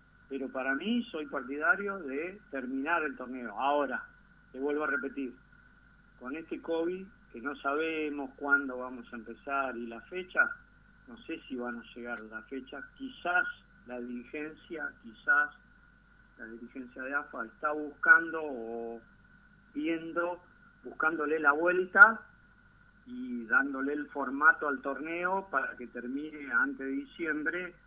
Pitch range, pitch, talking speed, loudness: 135-180 Hz, 145 Hz, 135 wpm, -31 LUFS